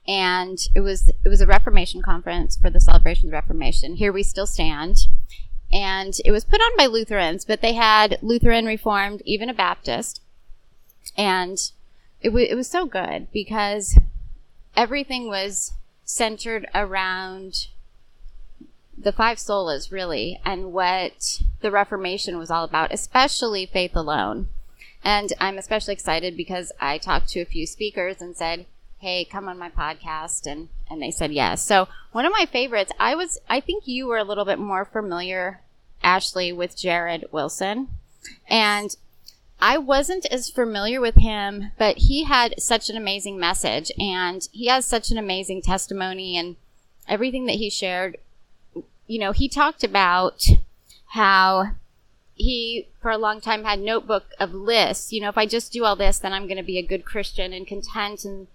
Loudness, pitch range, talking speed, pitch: -22 LUFS, 185-225 Hz, 165 wpm, 200 Hz